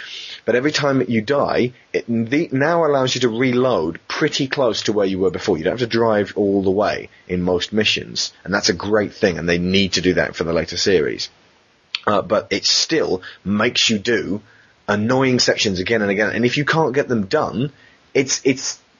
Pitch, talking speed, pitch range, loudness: 115 Hz, 210 wpm, 100-130 Hz, -18 LUFS